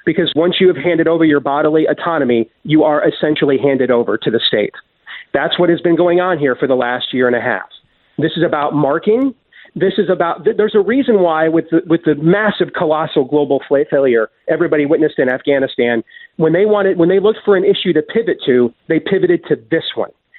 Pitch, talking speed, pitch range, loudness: 165 Hz, 210 wpm, 145-185 Hz, -14 LUFS